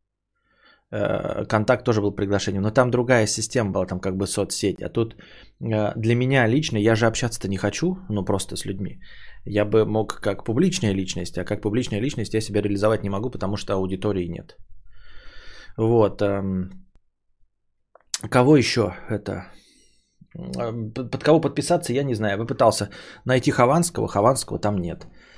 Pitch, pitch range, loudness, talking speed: 105 Hz, 100-125 Hz, -23 LUFS, 150 wpm